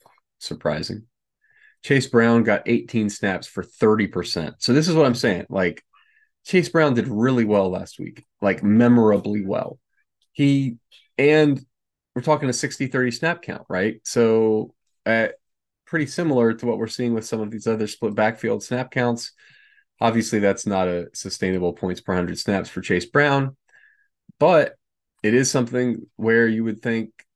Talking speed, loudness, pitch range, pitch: 155 wpm, -21 LUFS, 110-140 Hz, 115 Hz